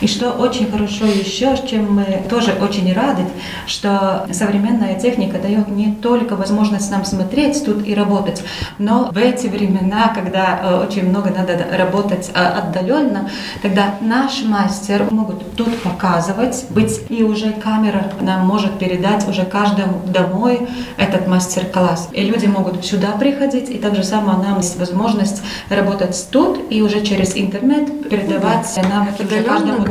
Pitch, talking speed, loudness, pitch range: 205 Hz, 145 wpm, -16 LUFS, 190-225 Hz